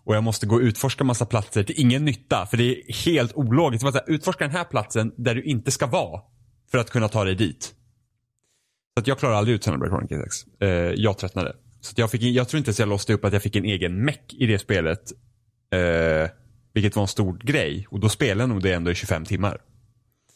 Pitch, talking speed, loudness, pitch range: 115 Hz, 225 wpm, -23 LUFS, 105-125 Hz